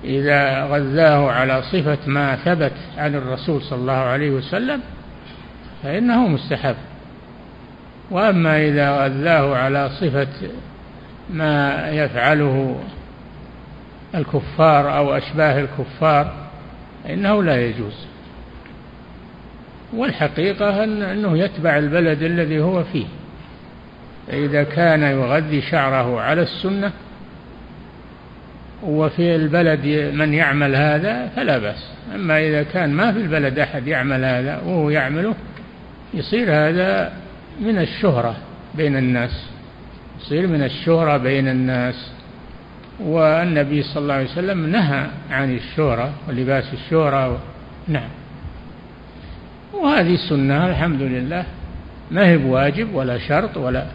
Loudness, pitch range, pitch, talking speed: -18 LUFS, 135-165 Hz, 150 Hz, 100 wpm